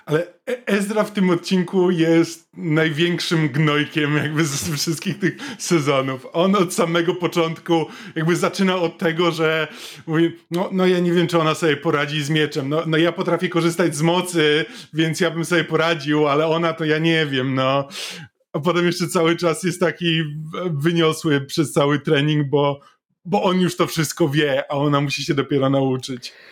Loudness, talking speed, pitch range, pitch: -20 LUFS, 175 wpm, 150-175 Hz, 165 Hz